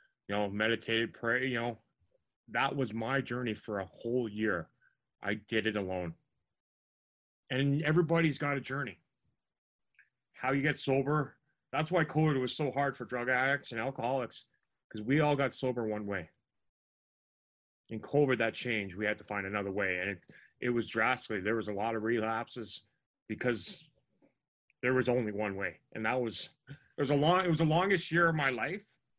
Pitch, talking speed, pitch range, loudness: 120 Hz, 180 wpm, 110-140 Hz, -33 LUFS